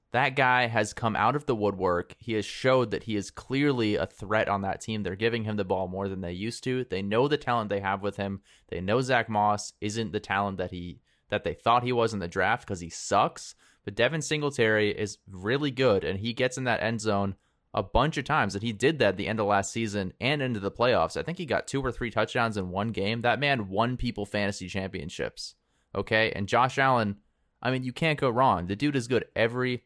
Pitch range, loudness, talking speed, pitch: 100-125 Hz, -28 LUFS, 245 wpm, 110 Hz